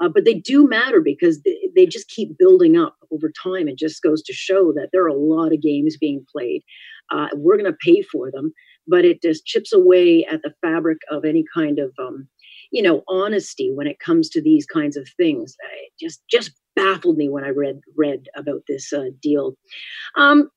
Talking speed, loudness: 210 wpm, -18 LUFS